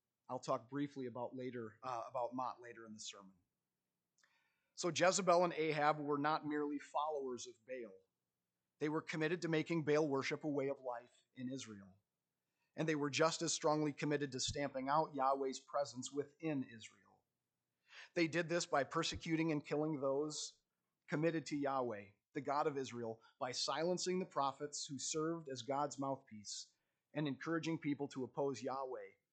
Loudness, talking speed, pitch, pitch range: -40 LUFS, 160 wpm, 145 Hz, 125-155 Hz